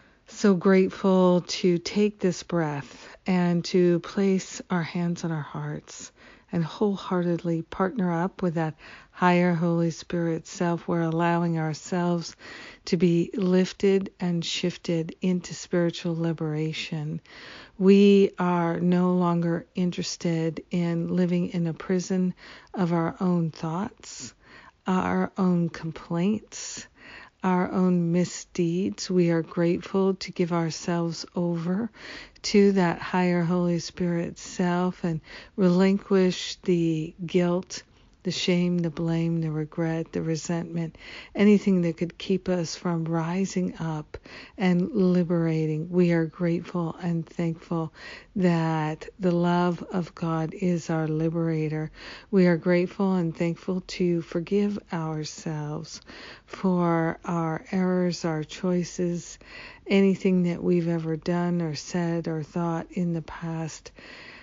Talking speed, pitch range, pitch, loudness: 120 wpm, 165-185 Hz, 175 Hz, -26 LUFS